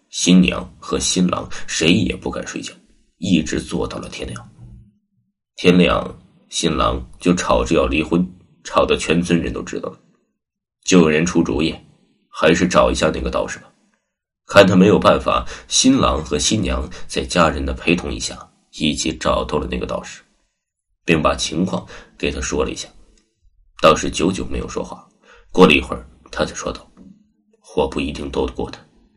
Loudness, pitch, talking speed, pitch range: -18 LUFS, 90 Hz, 240 characters per minute, 80-95 Hz